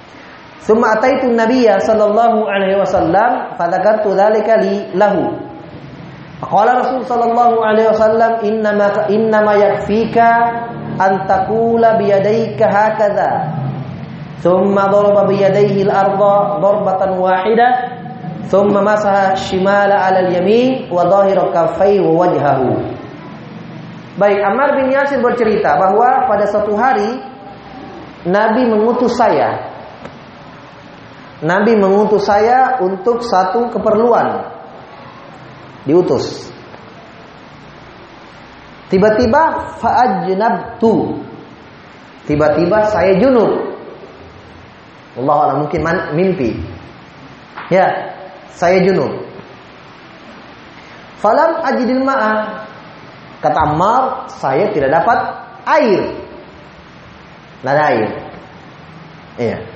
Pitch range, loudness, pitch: 190-230 Hz, -13 LUFS, 205 Hz